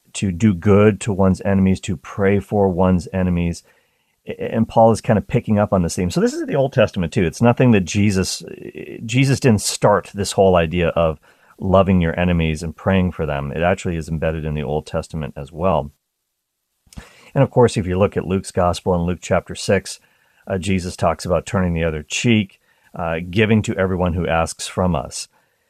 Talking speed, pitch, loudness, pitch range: 200 wpm, 95 Hz, -18 LUFS, 85-105 Hz